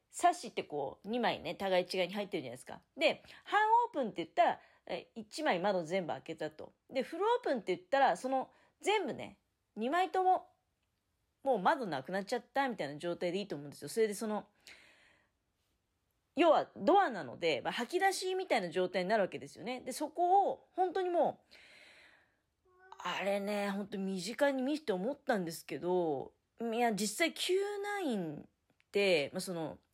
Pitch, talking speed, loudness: 230 Hz, 345 characters per minute, -35 LUFS